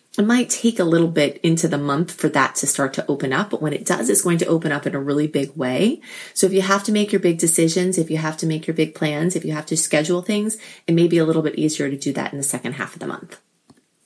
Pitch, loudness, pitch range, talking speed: 165 Hz, -20 LUFS, 150-180 Hz, 300 wpm